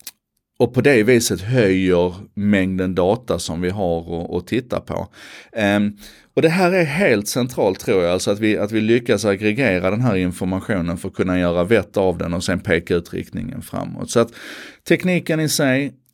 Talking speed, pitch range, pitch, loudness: 185 wpm, 95-125 Hz, 105 Hz, -19 LUFS